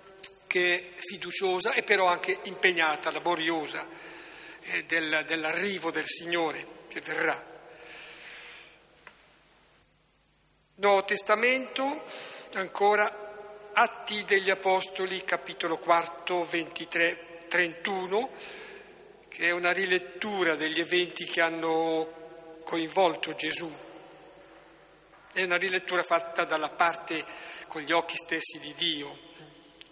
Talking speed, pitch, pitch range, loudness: 90 wpm, 175 Hz, 165-195 Hz, -28 LUFS